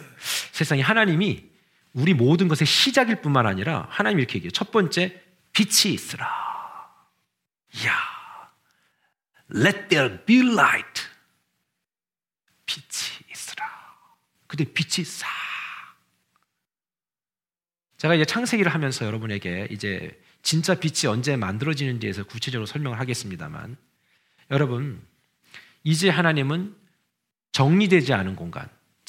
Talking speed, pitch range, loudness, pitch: 275 characters per minute, 115-185 Hz, -23 LUFS, 155 Hz